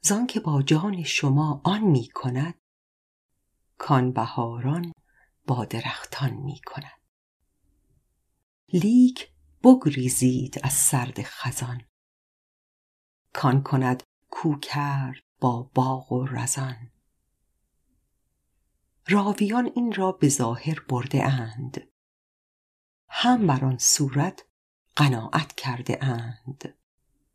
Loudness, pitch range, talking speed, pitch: -24 LUFS, 120-150 Hz, 85 wpm, 130 Hz